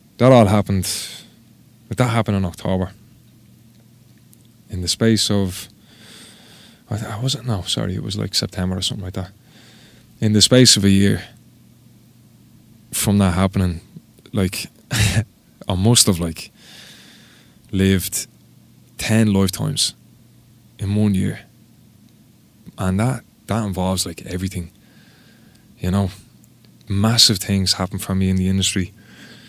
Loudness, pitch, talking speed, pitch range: -18 LUFS, 105 Hz, 120 wpm, 95-115 Hz